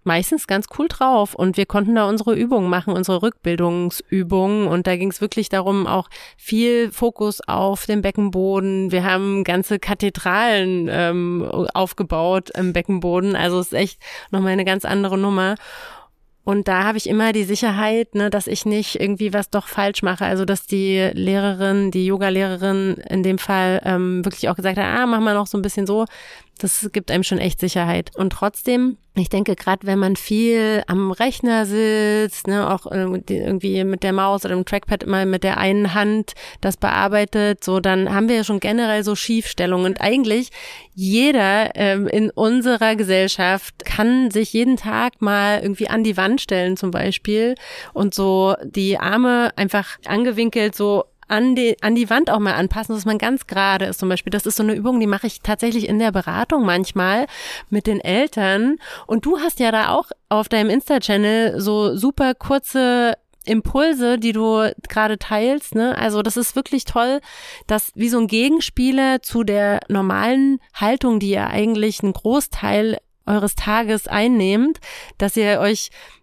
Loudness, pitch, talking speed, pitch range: -19 LUFS, 205 Hz, 175 wpm, 190-225 Hz